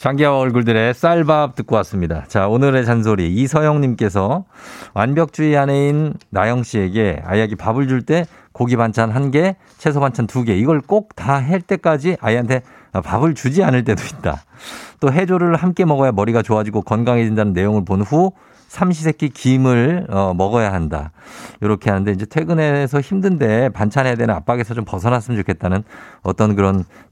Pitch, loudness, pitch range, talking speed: 125 Hz, -17 LUFS, 105-150 Hz, 350 characters per minute